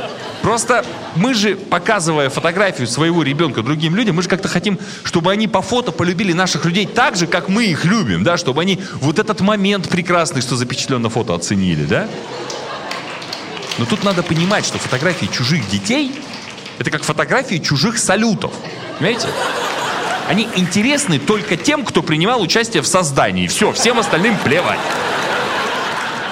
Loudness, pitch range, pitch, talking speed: -16 LUFS, 155-210 Hz, 180 Hz, 150 wpm